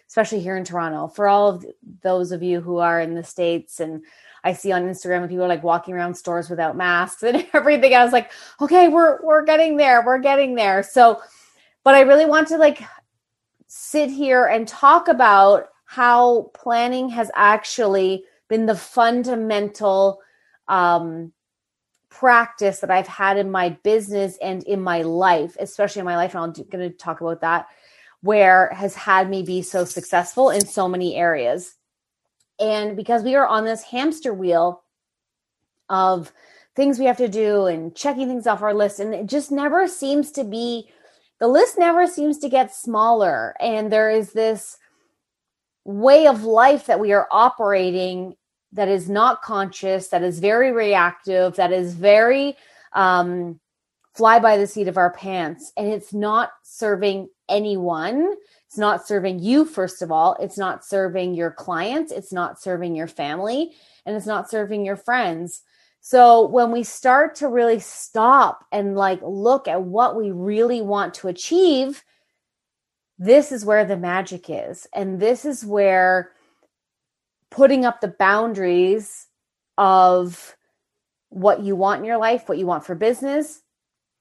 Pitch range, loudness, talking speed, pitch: 185-245 Hz, -18 LUFS, 165 wpm, 205 Hz